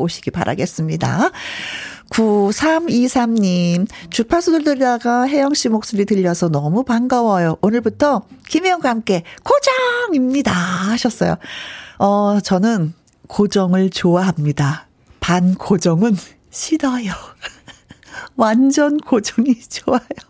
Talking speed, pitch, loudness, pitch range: 230 characters per minute, 220 Hz, -17 LUFS, 185-255 Hz